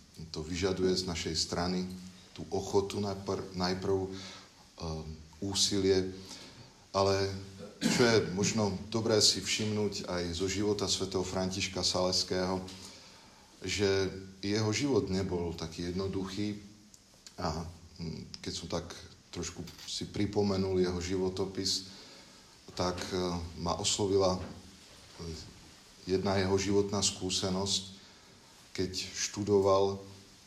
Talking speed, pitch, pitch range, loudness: 95 wpm, 95 Hz, 90-100 Hz, -32 LUFS